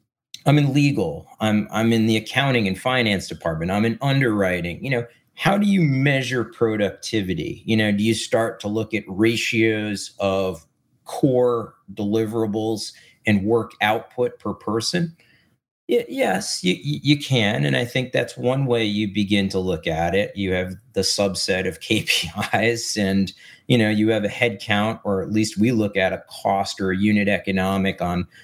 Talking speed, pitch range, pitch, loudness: 170 wpm, 100-120 Hz, 110 Hz, -21 LUFS